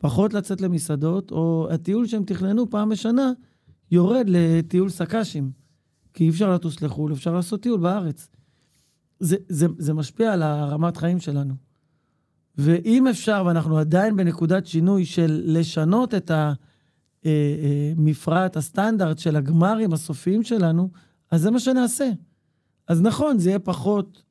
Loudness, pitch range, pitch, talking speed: -22 LUFS, 155-200 Hz, 170 Hz, 130 wpm